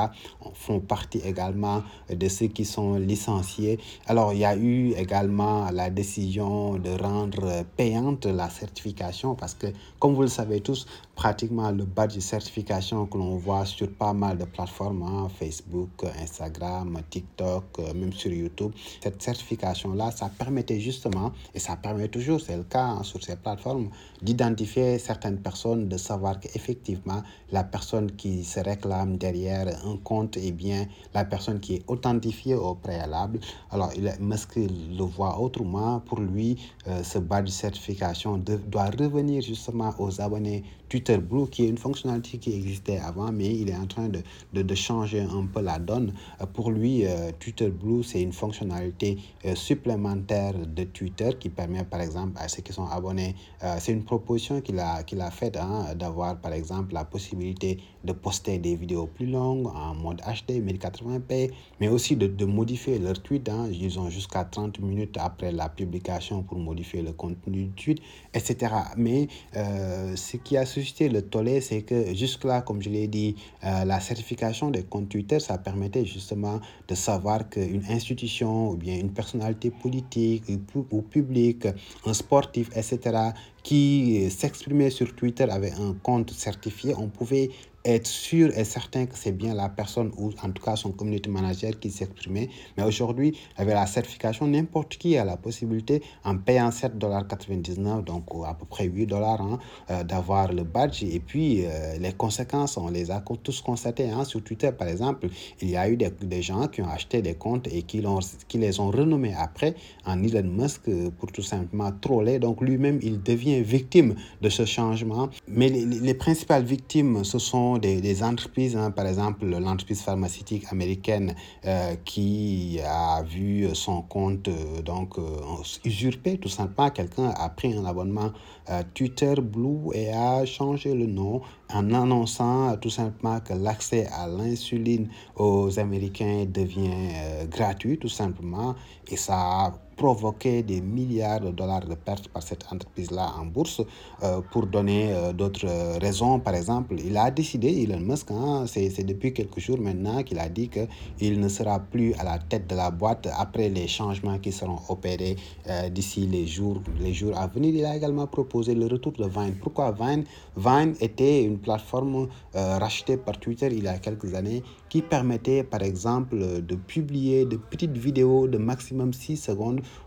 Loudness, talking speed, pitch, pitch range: -27 LUFS, 175 wpm, 105 Hz, 95-120 Hz